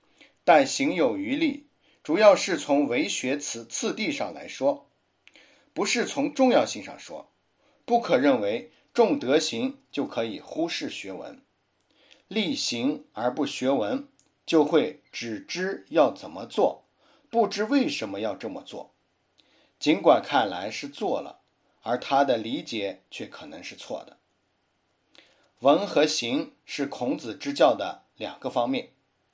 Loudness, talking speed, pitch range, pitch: -26 LUFS, 190 characters per minute, 190-285 Hz, 265 Hz